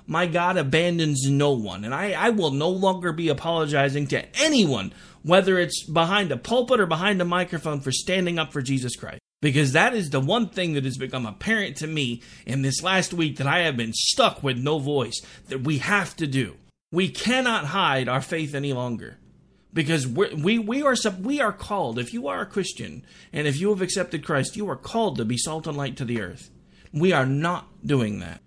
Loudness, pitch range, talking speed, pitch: -24 LUFS, 135-185 Hz, 215 wpm, 160 Hz